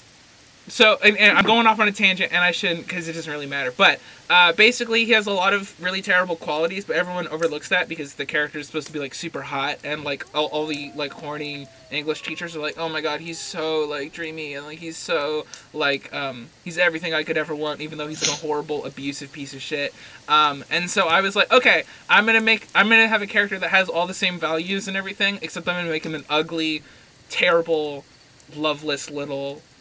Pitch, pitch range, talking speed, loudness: 160 Hz, 150-185 Hz, 230 wpm, -20 LUFS